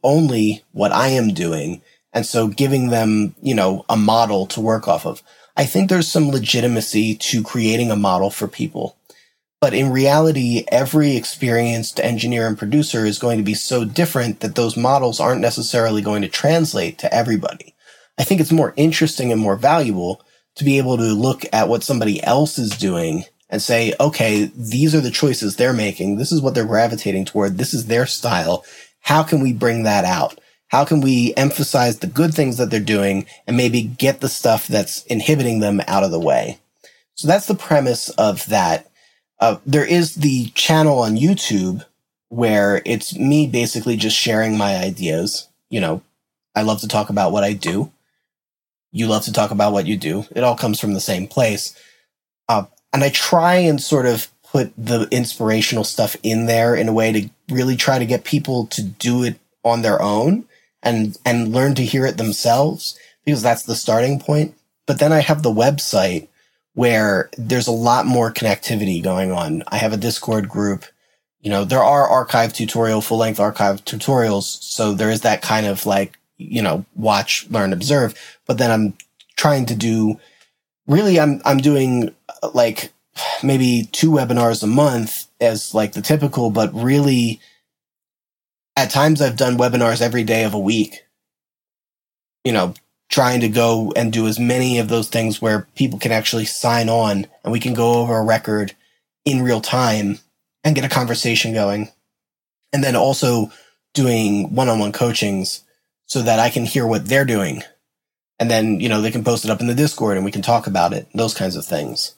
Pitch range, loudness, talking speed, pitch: 110-135 Hz, -18 LUFS, 185 wpm, 115 Hz